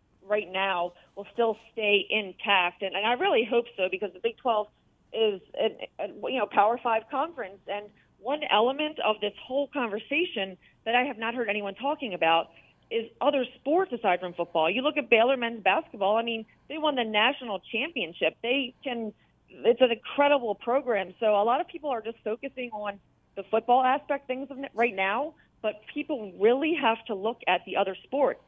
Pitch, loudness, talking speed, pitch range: 230 Hz, -27 LUFS, 190 wpm, 205-265 Hz